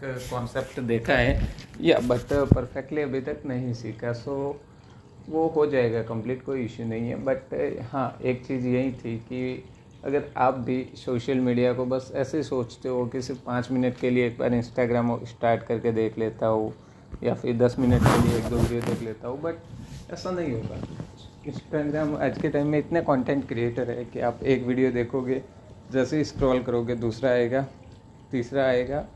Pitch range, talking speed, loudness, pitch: 120-135 Hz, 185 wpm, -26 LUFS, 125 Hz